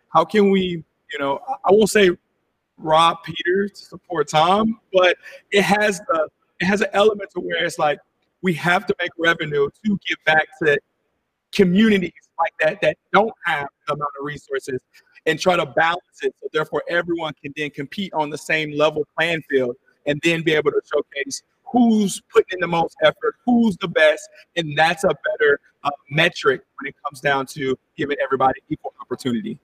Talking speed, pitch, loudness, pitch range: 185 wpm, 170 Hz, -20 LUFS, 150-200 Hz